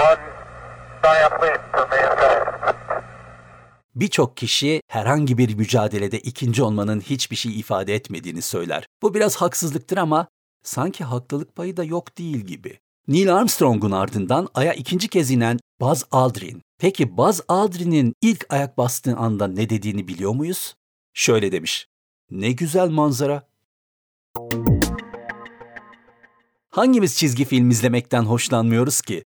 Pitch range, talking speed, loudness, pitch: 110-160 Hz, 110 wpm, -20 LUFS, 125 Hz